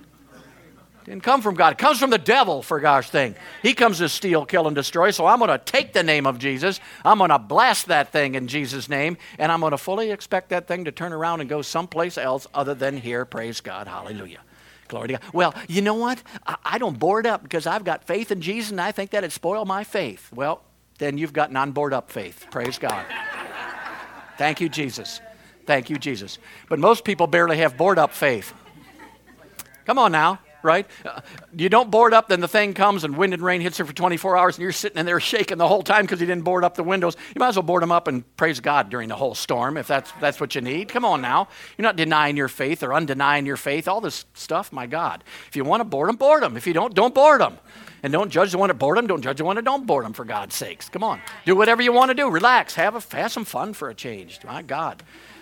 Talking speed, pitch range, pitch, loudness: 250 wpm, 150-205 Hz, 175 Hz, -21 LUFS